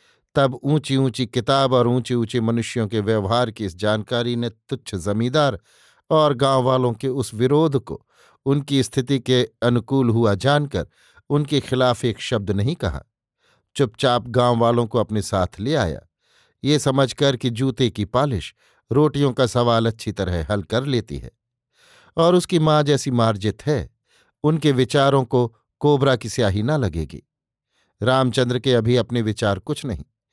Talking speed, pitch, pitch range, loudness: 155 wpm, 125 Hz, 110-135 Hz, -20 LUFS